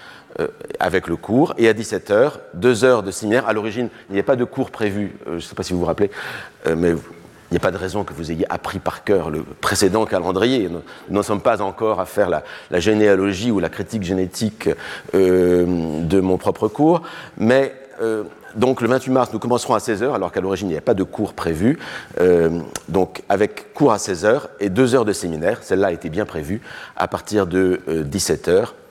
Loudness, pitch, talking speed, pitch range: -19 LUFS, 100 Hz, 220 wpm, 90-120 Hz